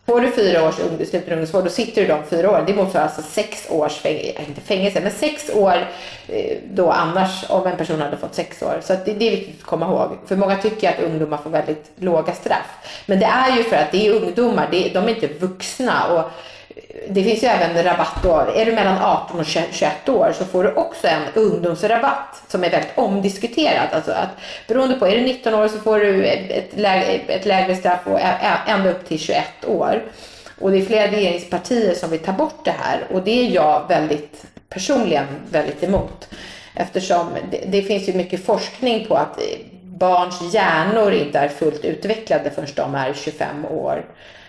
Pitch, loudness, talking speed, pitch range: 195 Hz, -19 LUFS, 200 wpm, 175-220 Hz